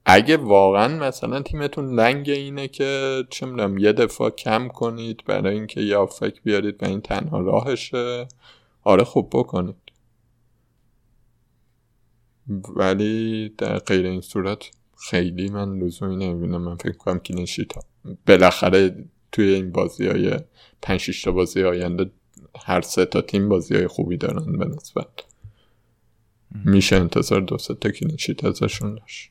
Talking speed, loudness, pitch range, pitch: 130 wpm, -21 LUFS, 95-115 Hz, 105 Hz